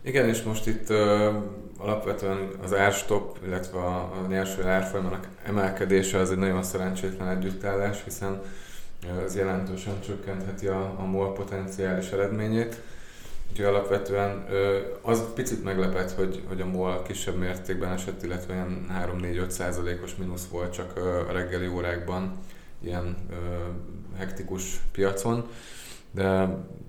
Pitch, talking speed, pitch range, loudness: 95 Hz, 125 wpm, 90-100 Hz, -29 LUFS